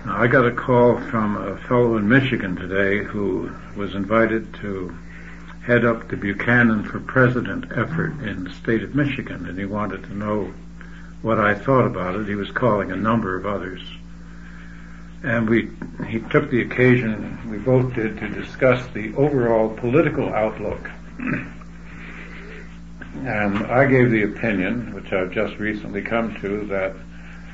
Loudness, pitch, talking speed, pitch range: -21 LUFS, 110 Hz, 155 wpm, 100-125 Hz